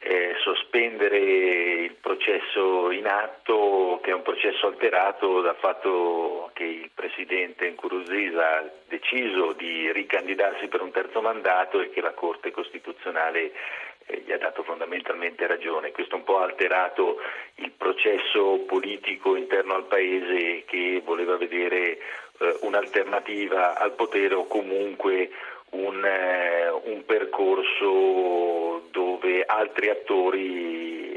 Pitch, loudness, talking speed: 385 Hz, -25 LUFS, 120 wpm